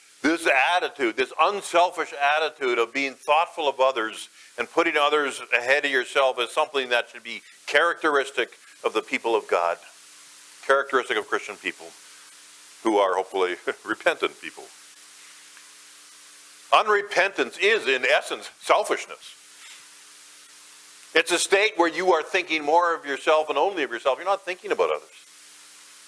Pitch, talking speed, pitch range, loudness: 155 Hz, 140 wpm, 120-185 Hz, -23 LUFS